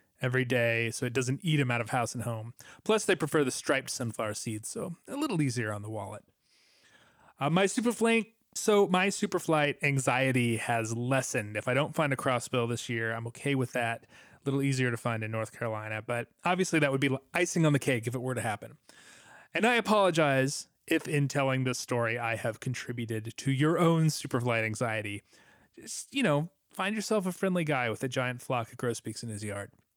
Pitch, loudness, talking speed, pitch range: 130 Hz, -30 LUFS, 205 wpm, 115-160 Hz